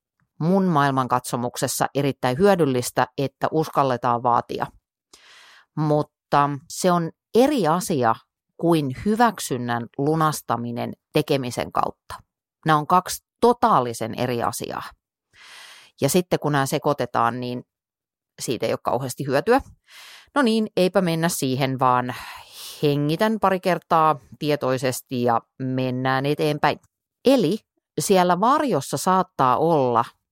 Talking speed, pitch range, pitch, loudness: 105 wpm, 125-175 Hz, 145 Hz, -22 LUFS